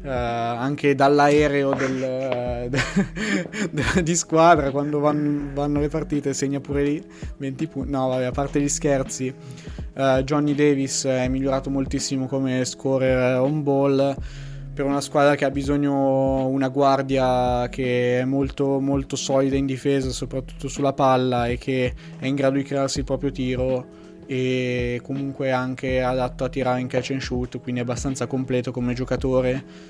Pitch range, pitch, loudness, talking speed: 130-140 Hz, 135 Hz, -22 LUFS, 155 wpm